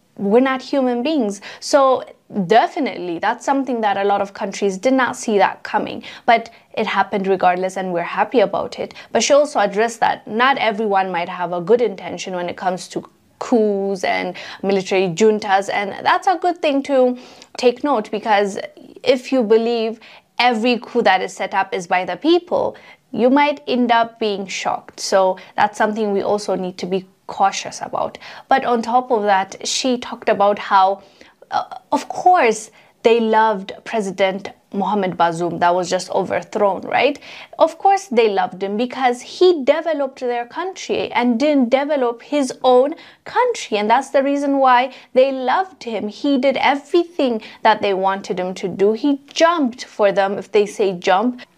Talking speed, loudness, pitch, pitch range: 170 wpm, -18 LUFS, 230 Hz, 195-270 Hz